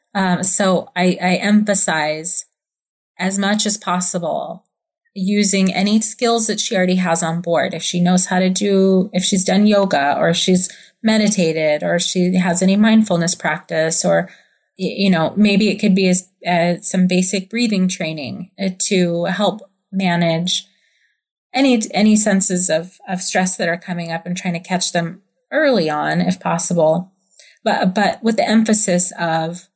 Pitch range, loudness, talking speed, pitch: 175-205 Hz, -16 LUFS, 155 wpm, 185 Hz